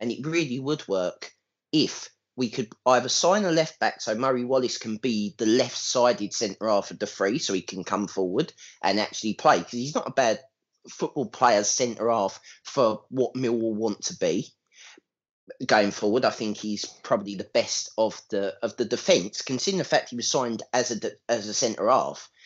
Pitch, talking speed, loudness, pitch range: 120 Hz, 200 wpm, -26 LUFS, 110-130 Hz